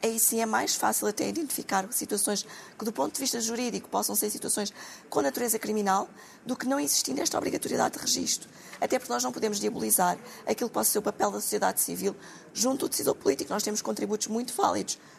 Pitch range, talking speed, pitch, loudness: 205-255 Hz, 205 wpm, 225 Hz, -28 LUFS